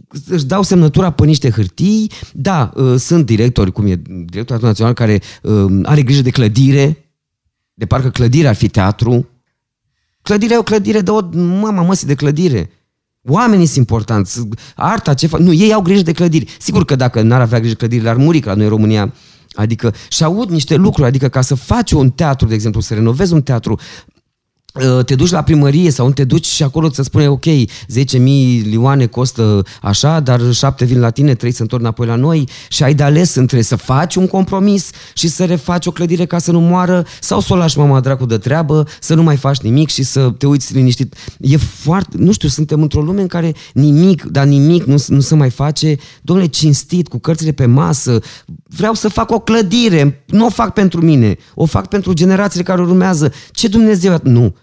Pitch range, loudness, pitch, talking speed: 120-170 Hz, -12 LUFS, 140 Hz, 200 wpm